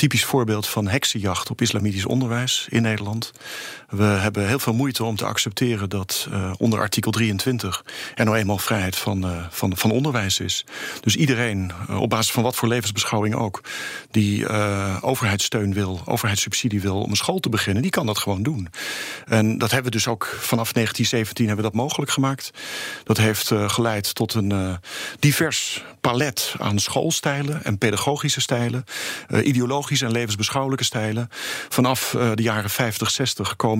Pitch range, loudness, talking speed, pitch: 105-125 Hz, -22 LUFS, 175 wpm, 110 Hz